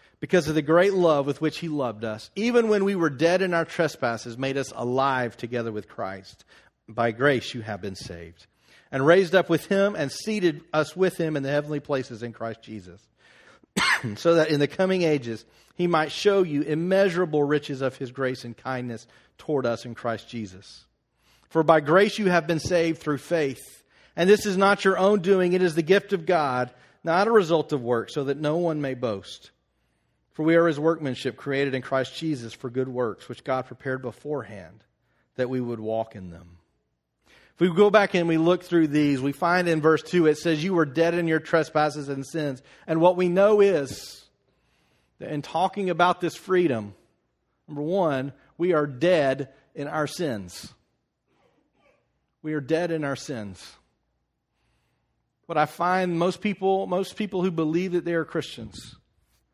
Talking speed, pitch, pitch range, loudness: 185 wpm, 150 Hz, 125-175 Hz, -24 LUFS